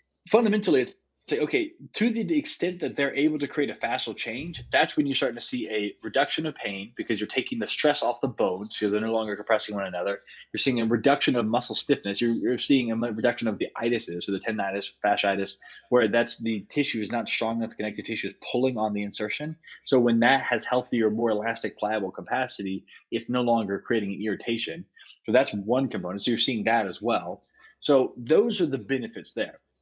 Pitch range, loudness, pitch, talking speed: 105-140 Hz, -26 LUFS, 115 Hz, 210 wpm